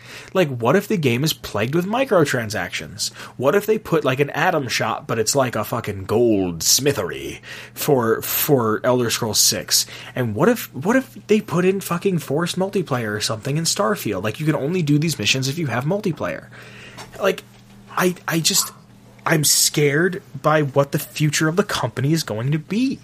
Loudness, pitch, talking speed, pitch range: -20 LUFS, 145 Hz, 190 wpm, 125-180 Hz